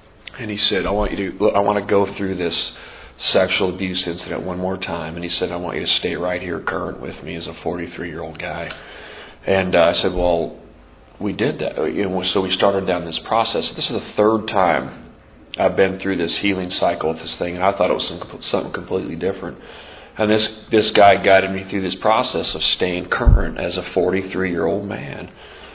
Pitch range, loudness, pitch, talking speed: 85-100 Hz, -20 LUFS, 95 Hz, 220 wpm